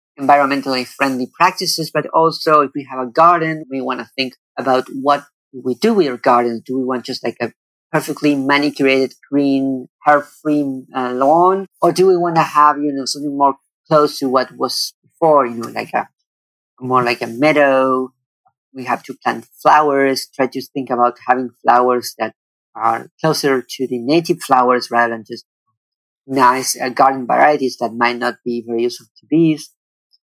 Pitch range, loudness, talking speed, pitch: 125-150 Hz, -16 LUFS, 175 wpm, 135 Hz